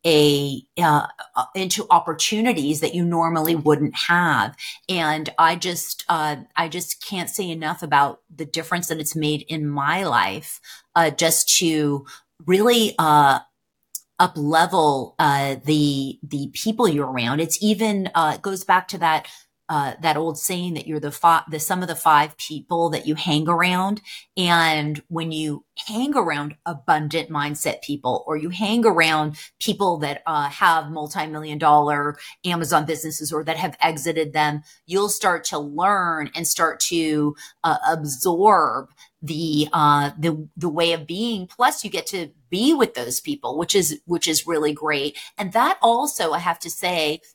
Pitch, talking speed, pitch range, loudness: 160 Hz, 160 wpm, 150-175 Hz, -21 LUFS